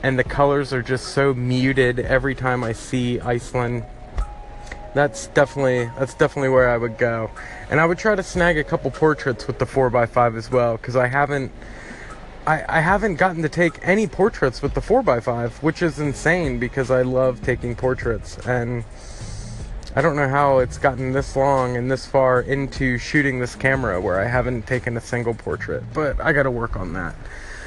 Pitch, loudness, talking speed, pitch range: 130 Hz, -20 LUFS, 185 wpm, 120-140 Hz